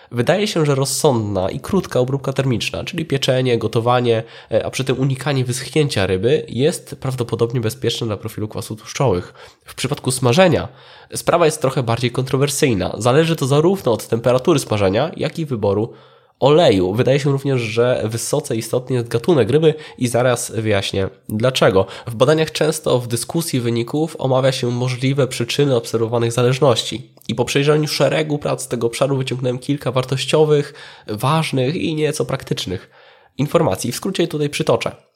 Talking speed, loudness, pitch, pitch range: 150 wpm, -18 LUFS, 130 Hz, 115-145 Hz